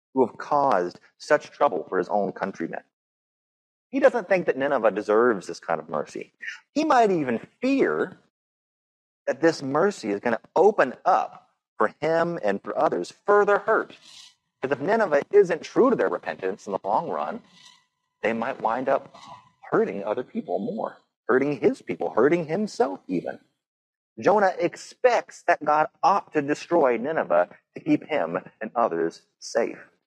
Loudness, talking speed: -24 LUFS, 155 wpm